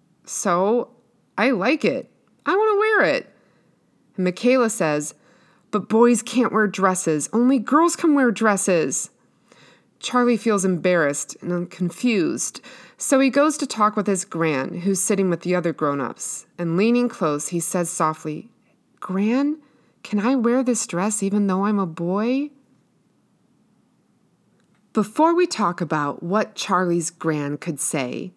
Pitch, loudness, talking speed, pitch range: 210 Hz, -21 LUFS, 140 wpm, 175-245 Hz